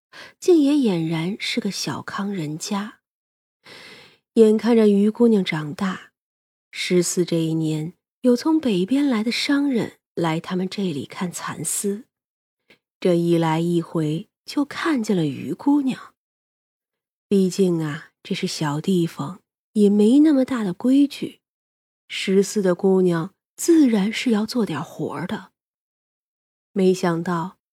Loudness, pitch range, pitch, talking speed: -21 LUFS, 170-230 Hz, 195 Hz, 180 characters per minute